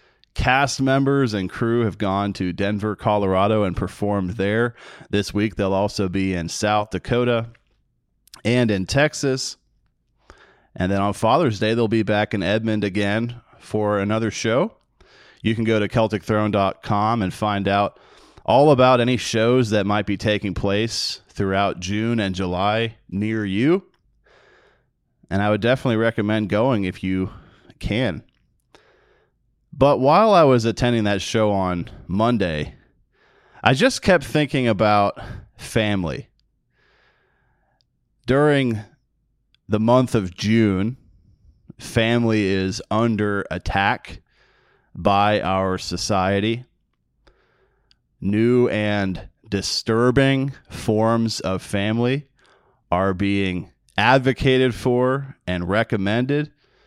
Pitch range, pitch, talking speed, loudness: 100-120 Hz, 105 Hz, 115 wpm, -20 LUFS